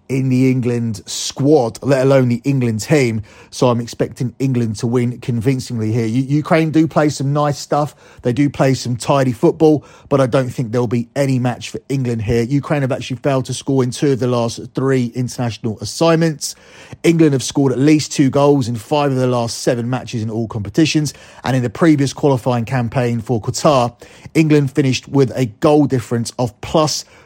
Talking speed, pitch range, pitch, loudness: 195 wpm, 120-145 Hz, 130 Hz, -16 LUFS